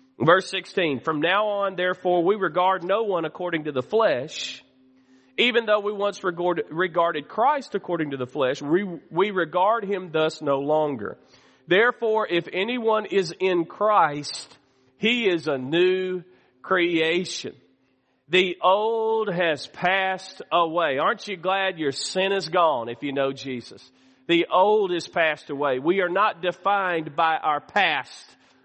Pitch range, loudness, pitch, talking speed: 150-195 Hz, -23 LUFS, 180 Hz, 150 wpm